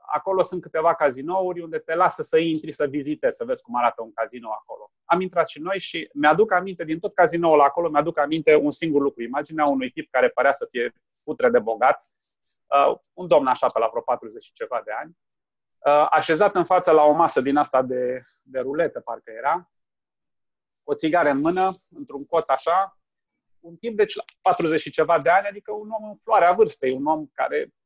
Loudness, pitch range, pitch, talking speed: -22 LUFS, 145-195 Hz, 165 Hz, 200 wpm